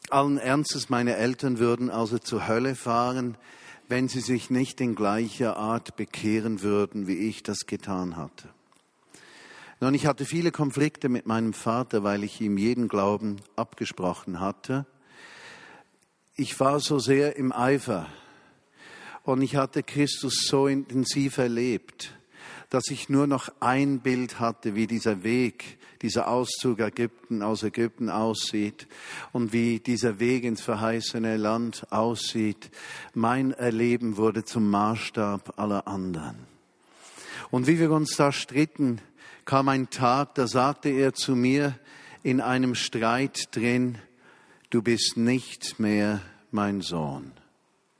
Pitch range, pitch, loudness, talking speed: 110-135 Hz, 120 Hz, -26 LUFS, 135 wpm